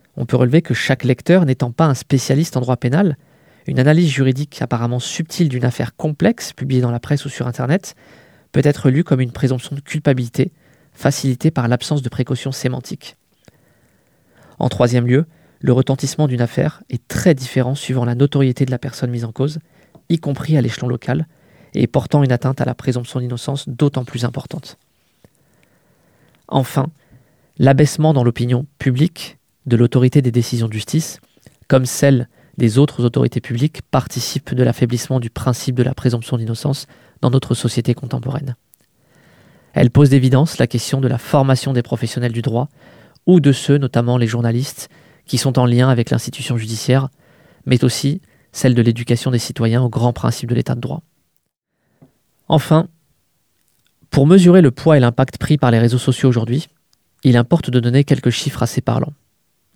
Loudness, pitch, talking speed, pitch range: -17 LUFS, 130 Hz, 170 wpm, 125-145 Hz